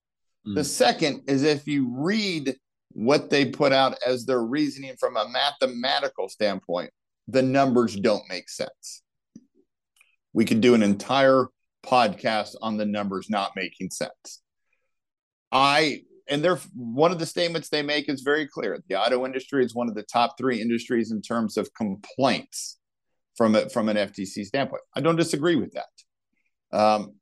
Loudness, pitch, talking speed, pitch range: -24 LUFS, 130 Hz, 160 wpm, 115-145 Hz